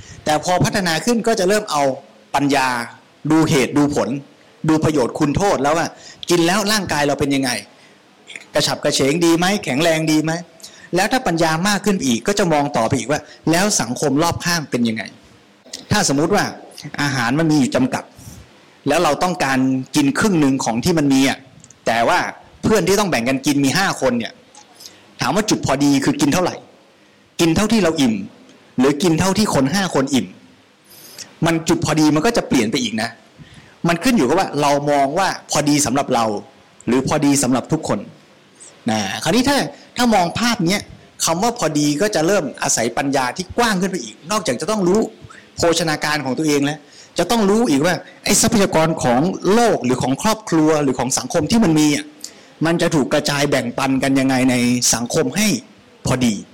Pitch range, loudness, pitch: 140-195 Hz, -17 LUFS, 155 Hz